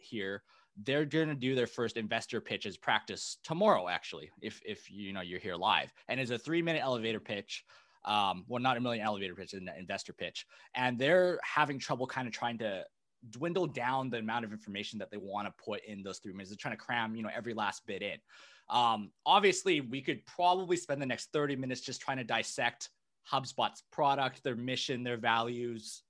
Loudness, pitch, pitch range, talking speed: -34 LUFS, 125 Hz, 110-140 Hz, 200 wpm